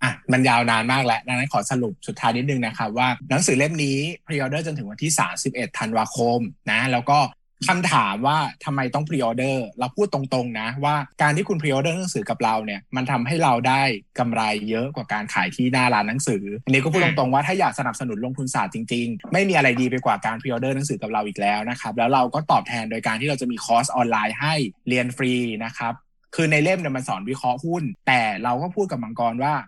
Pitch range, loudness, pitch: 115-145 Hz, -22 LUFS, 130 Hz